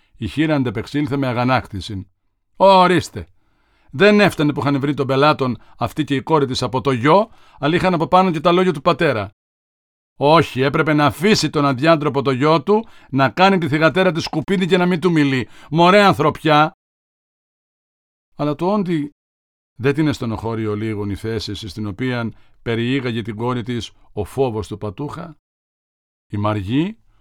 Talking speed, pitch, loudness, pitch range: 165 wpm, 140 Hz, -17 LUFS, 110-160 Hz